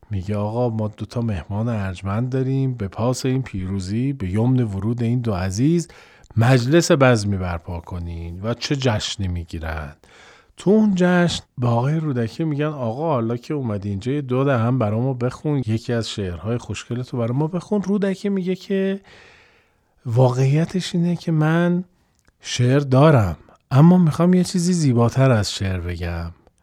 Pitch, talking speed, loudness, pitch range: 125 Hz, 150 wpm, -20 LUFS, 105-155 Hz